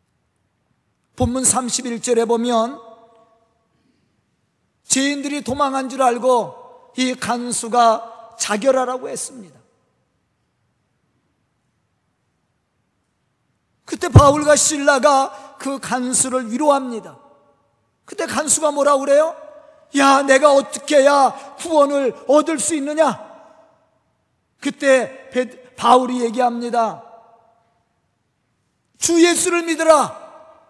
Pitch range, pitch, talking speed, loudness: 240-295 Hz, 270 Hz, 175 characters per minute, -17 LUFS